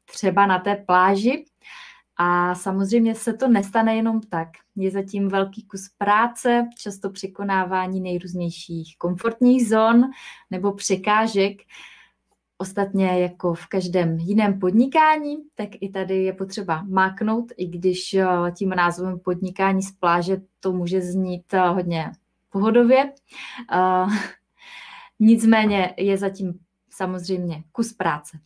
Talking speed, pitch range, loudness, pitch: 115 wpm, 185-220 Hz, -21 LUFS, 195 Hz